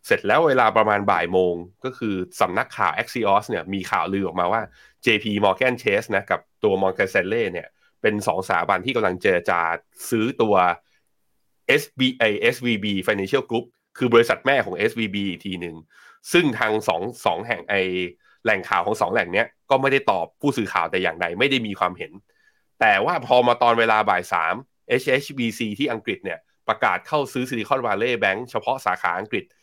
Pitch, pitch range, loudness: 110 Hz, 95-130 Hz, -21 LUFS